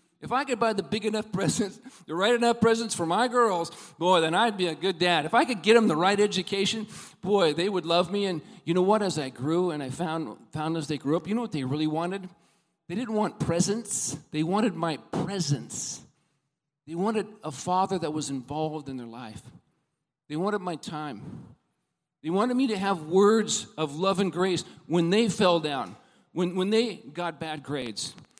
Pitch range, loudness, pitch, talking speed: 155-205 Hz, -27 LUFS, 180 Hz, 205 wpm